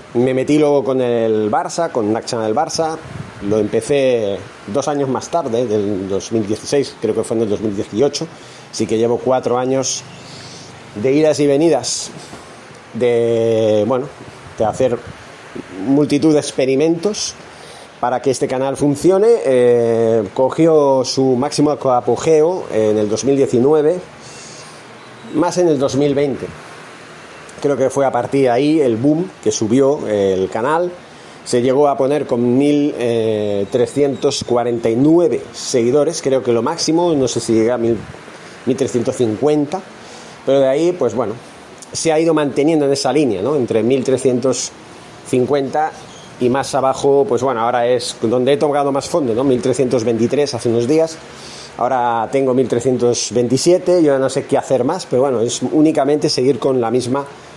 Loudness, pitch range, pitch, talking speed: -16 LUFS, 120-145 Hz, 130 Hz, 145 wpm